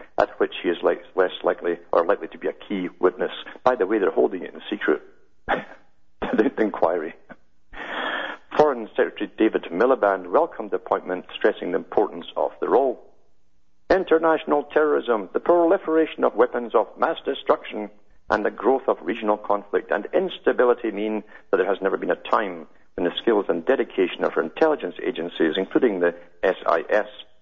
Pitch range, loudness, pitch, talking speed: 85-125 Hz, -23 LUFS, 105 Hz, 160 wpm